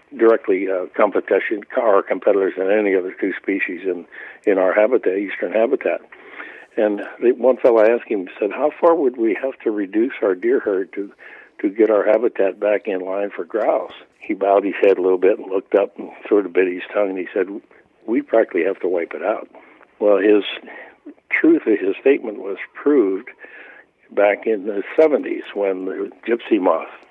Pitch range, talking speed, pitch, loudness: 315-430 Hz, 185 wpm, 380 Hz, -19 LUFS